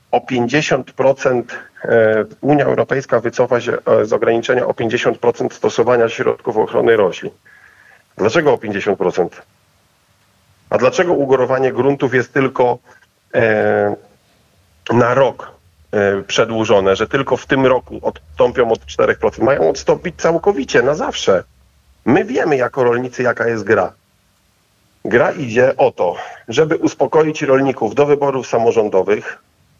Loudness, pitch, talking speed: -15 LUFS, 135 Hz, 115 wpm